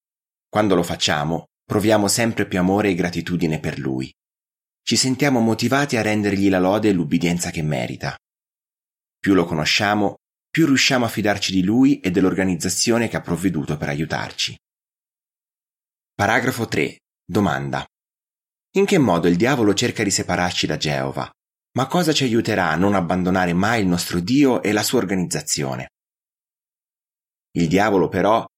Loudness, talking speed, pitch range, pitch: -20 LUFS, 145 wpm, 85-115 Hz, 100 Hz